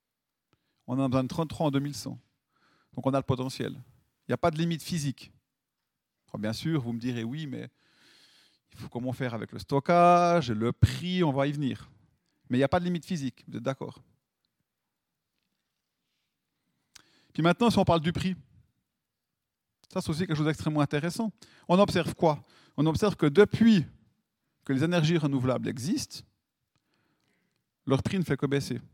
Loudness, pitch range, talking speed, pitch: -28 LUFS, 130-170 Hz, 175 wpm, 145 Hz